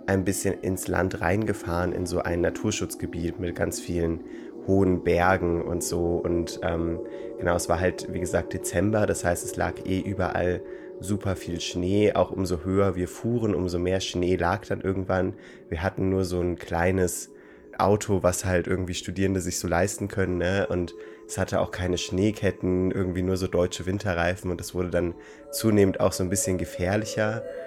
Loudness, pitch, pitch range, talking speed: -26 LUFS, 90 Hz, 85-95 Hz, 180 wpm